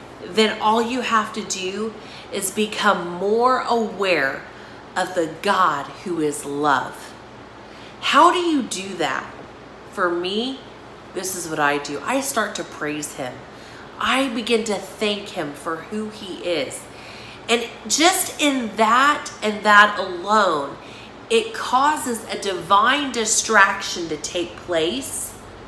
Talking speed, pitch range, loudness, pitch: 135 wpm, 175-230 Hz, -20 LUFS, 205 Hz